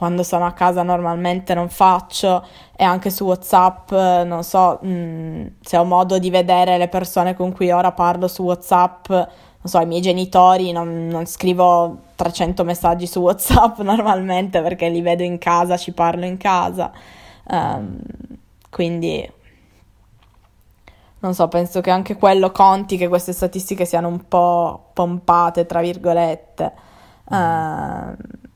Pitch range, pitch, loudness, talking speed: 170-185 Hz, 180 Hz, -17 LUFS, 145 wpm